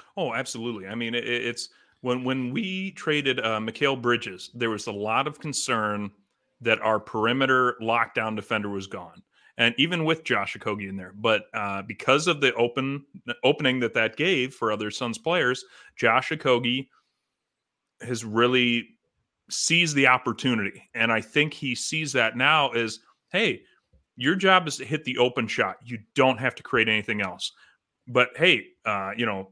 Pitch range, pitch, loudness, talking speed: 110-135 Hz, 120 Hz, -24 LUFS, 170 wpm